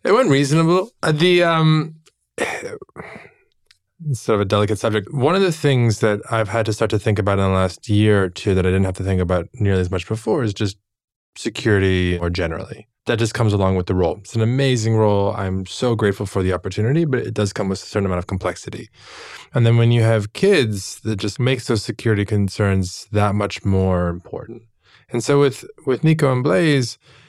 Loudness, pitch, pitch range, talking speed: -19 LUFS, 110 Hz, 100-125 Hz, 210 wpm